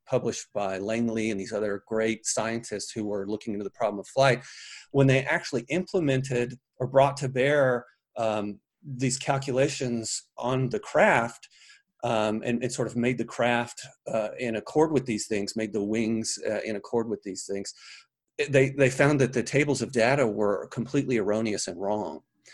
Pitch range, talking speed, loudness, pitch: 110-130 Hz, 175 wpm, -27 LUFS, 115 Hz